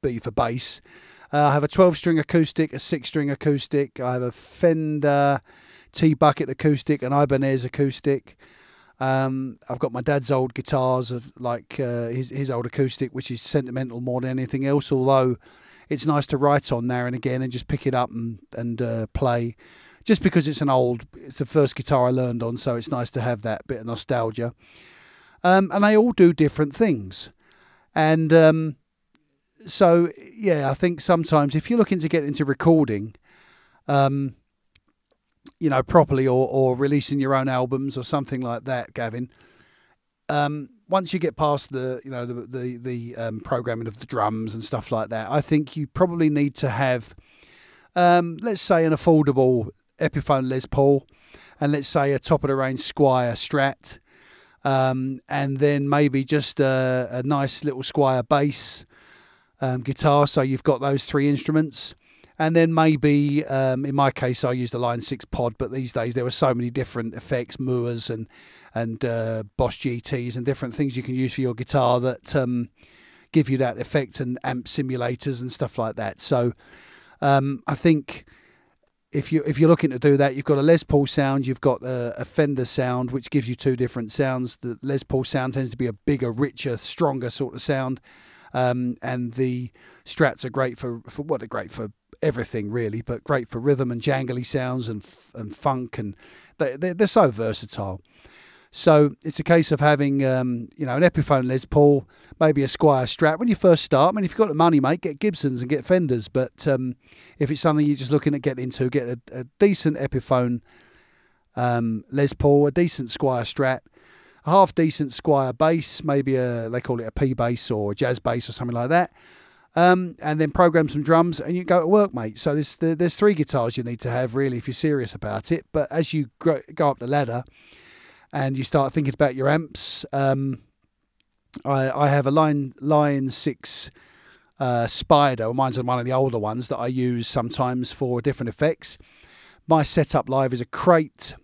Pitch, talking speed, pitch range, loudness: 135 Hz, 195 wpm, 125-150 Hz, -22 LUFS